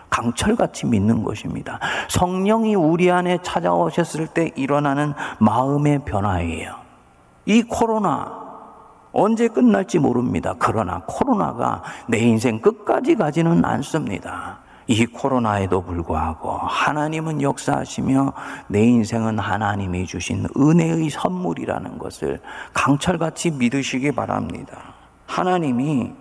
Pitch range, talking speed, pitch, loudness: 105-170 Hz, 280 characters per minute, 140 Hz, -20 LUFS